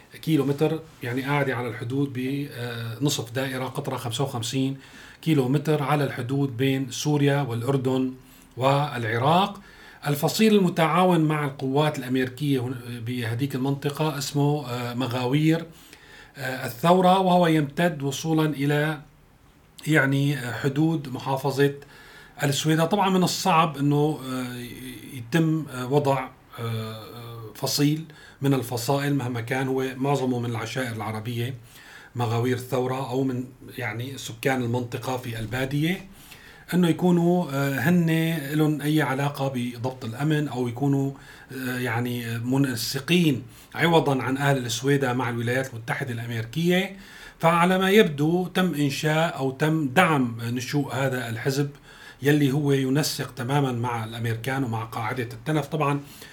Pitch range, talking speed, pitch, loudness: 125-150 Hz, 110 wpm, 140 Hz, -24 LUFS